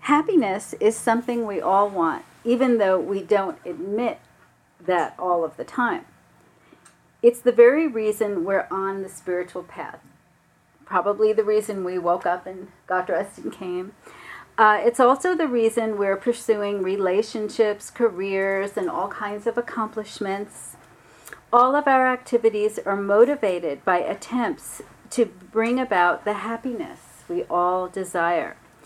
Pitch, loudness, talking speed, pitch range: 210 Hz, -22 LUFS, 135 wpm, 190-235 Hz